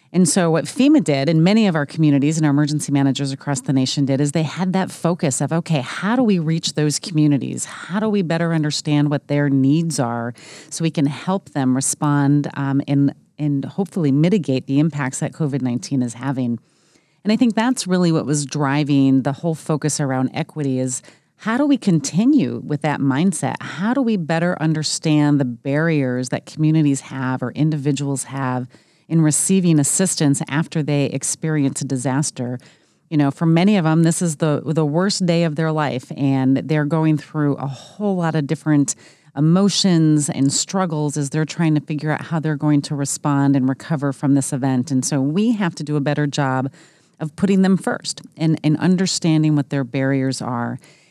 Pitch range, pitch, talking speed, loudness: 140-165 Hz, 150 Hz, 190 wpm, -19 LUFS